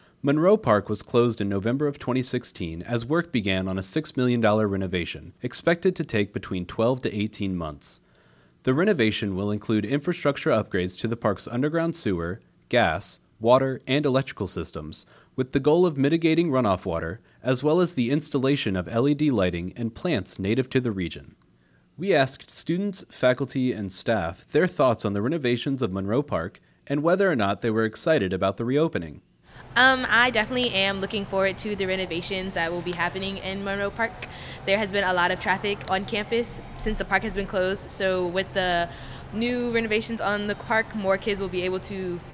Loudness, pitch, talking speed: -25 LUFS, 140 Hz, 185 wpm